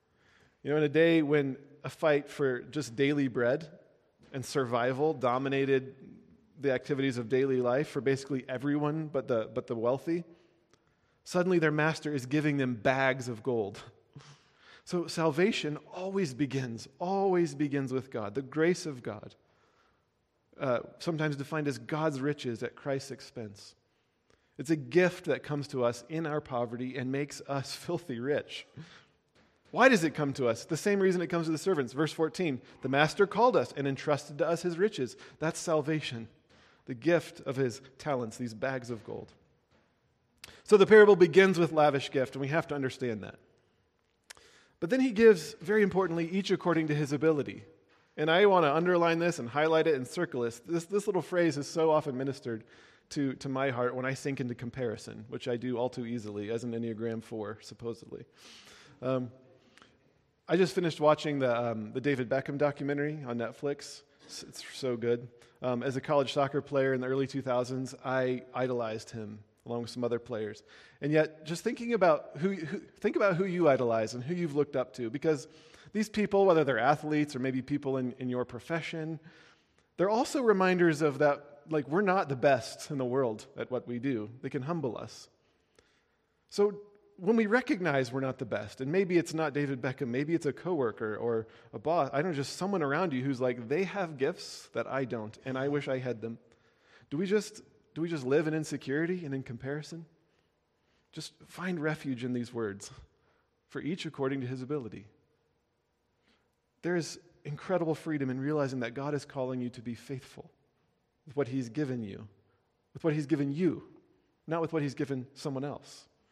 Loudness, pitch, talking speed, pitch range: -31 LUFS, 140 Hz, 185 wpm, 125-160 Hz